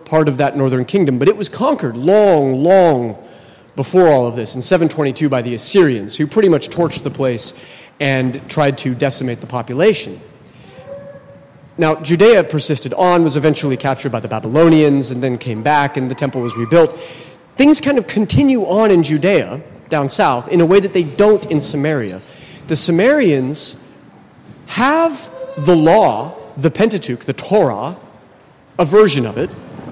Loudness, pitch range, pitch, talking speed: -14 LUFS, 135-180 Hz, 150 Hz, 160 wpm